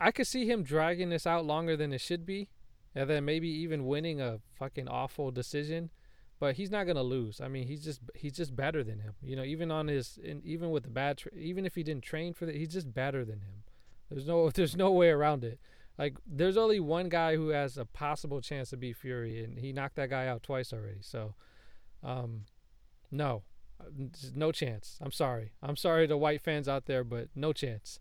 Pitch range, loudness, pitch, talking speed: 130-160 Hz, -34 LUFS, 145 Hz, 225 wpm